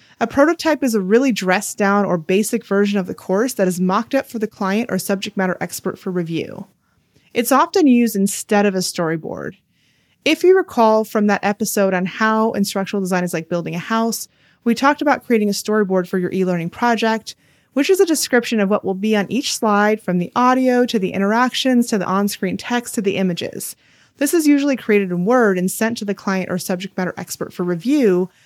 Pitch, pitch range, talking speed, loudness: 210 Hz, 190-240 Hz, 210 wpm, -18 LUFS